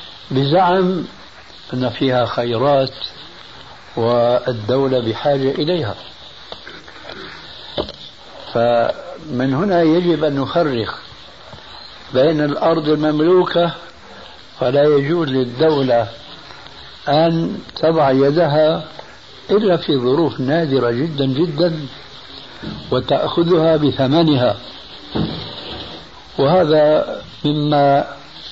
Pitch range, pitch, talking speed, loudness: 130-165 Hz, 145 Hz, 65 wpm, -17 LUFS